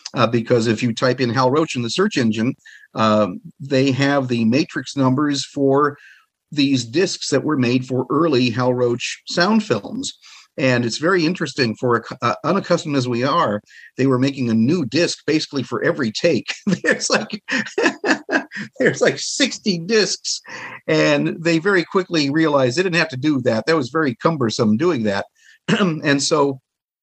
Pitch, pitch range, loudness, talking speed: 140 Hz, 125-170 Hz, -19 LUFS, 170 wpm